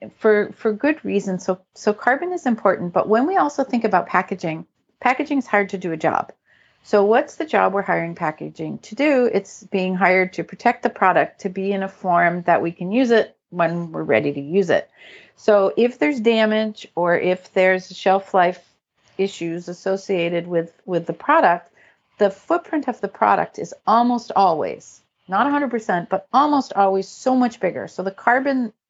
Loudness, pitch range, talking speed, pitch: -20 LUFS, 180-240 Hz, 185 wpm, 195 Hz